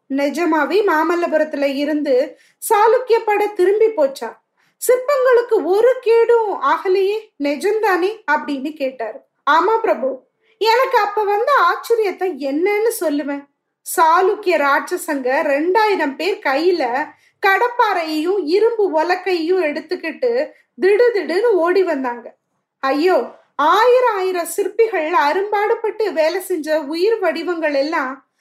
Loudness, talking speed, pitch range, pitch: -17 LUFS, 80 wpm, 310-435 Hz, 365 Hz